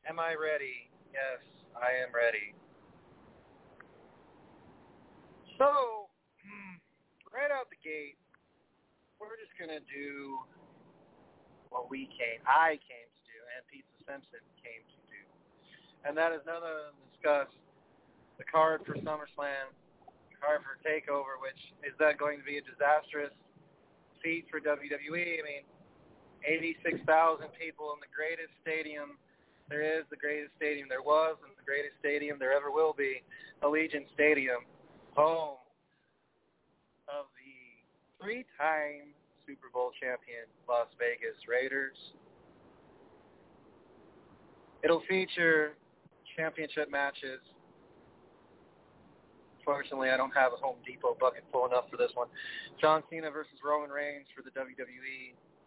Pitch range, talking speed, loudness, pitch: 140-165 Hz, 125 wpm, -33 LUFS, 150 Hz